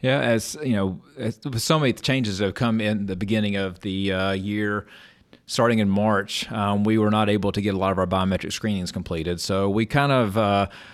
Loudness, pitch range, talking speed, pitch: -23 LUFS, 95-115 Hz, 215 wpm, 105 Hz